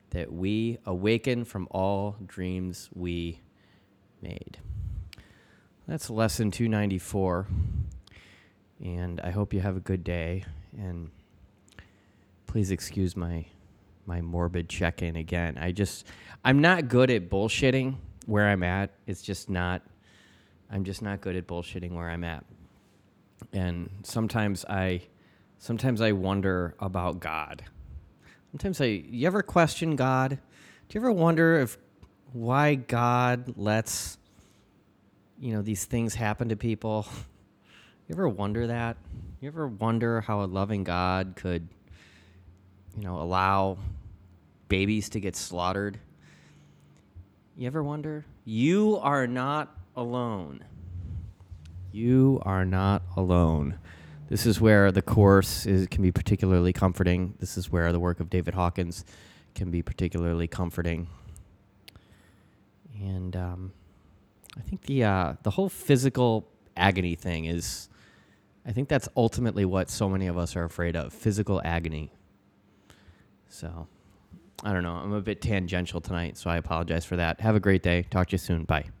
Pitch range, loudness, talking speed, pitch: 90-110 Hz, -28 LUFS, 135 wpm, 95 Hz